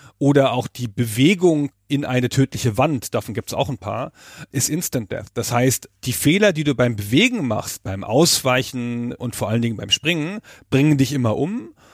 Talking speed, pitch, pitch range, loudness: 190 wpm, 130 Hz, 120-145 Hz, -20 LUFS